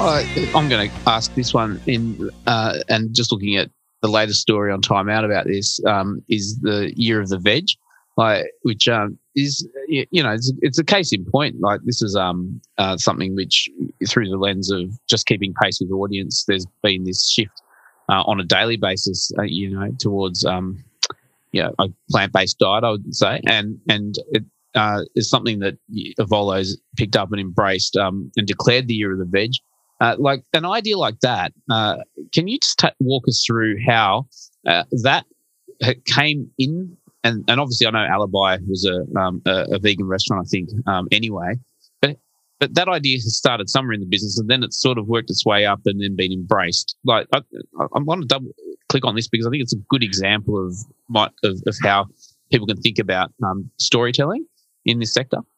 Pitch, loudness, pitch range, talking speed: 110 Hz, -19 LUFS, 100-130 Hz, 205 wpm